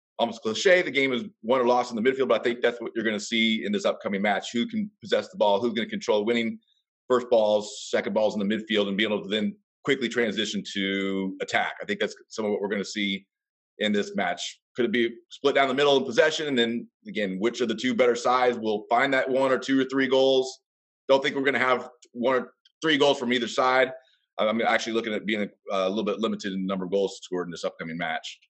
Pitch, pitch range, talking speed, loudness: 120 Hz, 105-130 Hz, 255 wpm, -25 LUFS